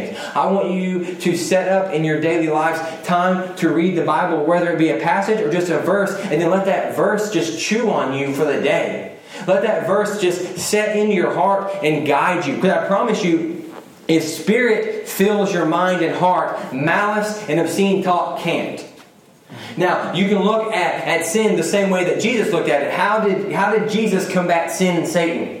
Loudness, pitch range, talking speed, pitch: -18 LUFS, 165-200 Hz, 205 wpm, 180 Hz